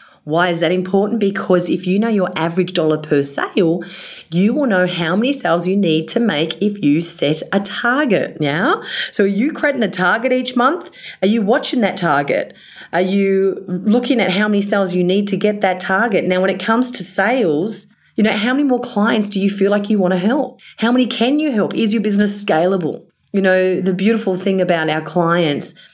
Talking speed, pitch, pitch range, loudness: 215 wpm, 195 Hz, 180-225 Hz, -16 LUFS